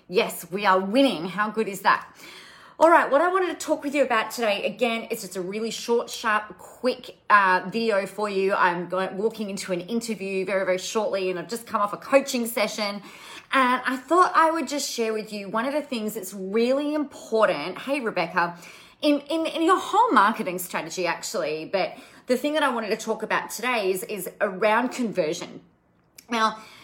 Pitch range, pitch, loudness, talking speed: 195-275 Hz, 220 Hz, -24 LUFS, 200 wpm